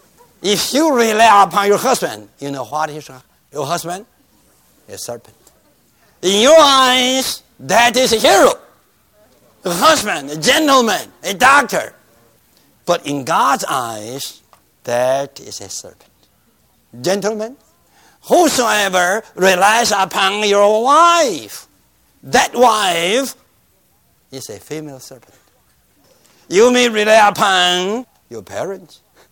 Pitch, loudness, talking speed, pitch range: 200 Hz, -13 LUFS, 110 wpm, 150-240 Hz